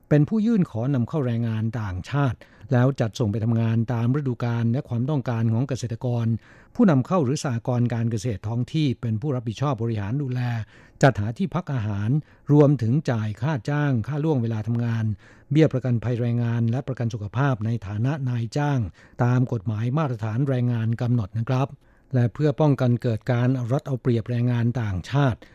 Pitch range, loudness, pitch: 115-140 Hz, -24 LUFS, 125 Hz